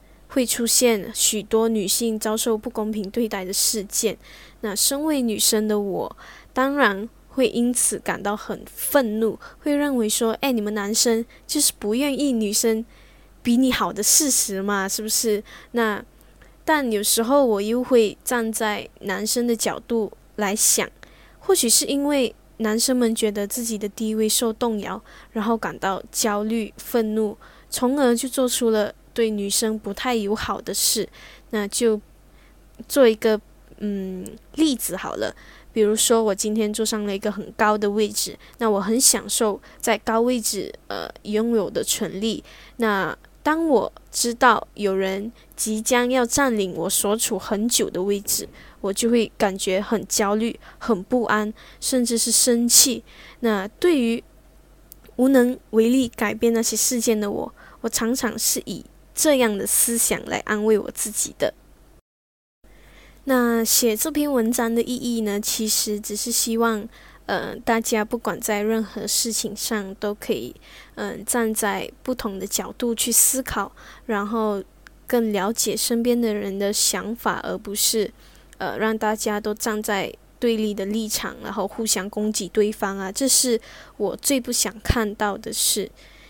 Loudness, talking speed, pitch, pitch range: -21 LUFS, 220 characters per minute, 220 Hz, 210-240 Hz